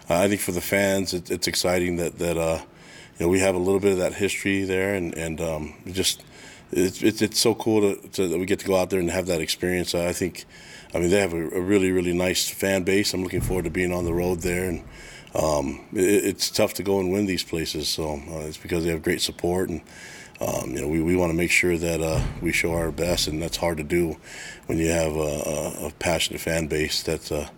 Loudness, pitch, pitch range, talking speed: -24 LUFS, 90 Hz, 80-95 Hz, 255 wpm